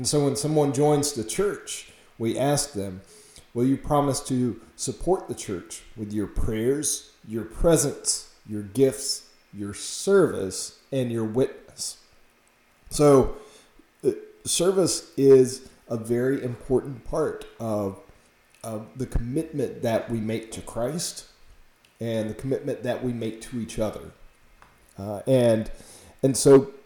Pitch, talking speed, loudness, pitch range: 130 Hz, 130 wpm, -25 LUFS, 110-145 Hz